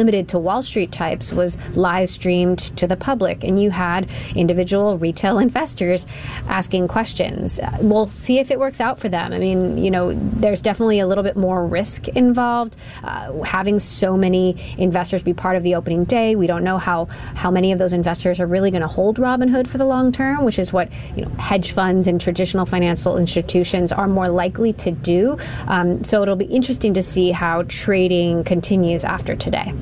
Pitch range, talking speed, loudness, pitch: 180-205 Hz, 195 wpm, -19 LUFS, 185 Hz